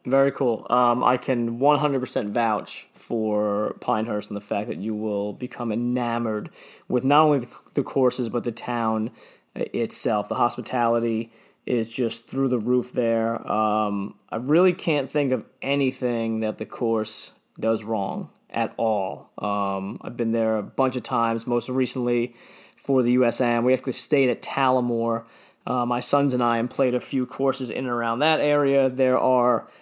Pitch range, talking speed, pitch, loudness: 115-130 Hz, 170 wpm, 120 Hz, -24 LUFS